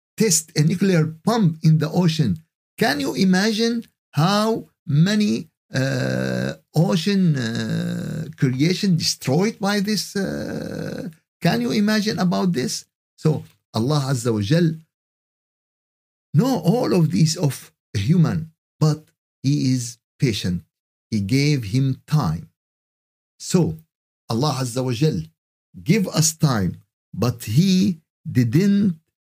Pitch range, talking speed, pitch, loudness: 135-185 Hz, 115 wpm, 160 Hz, -21 LUFS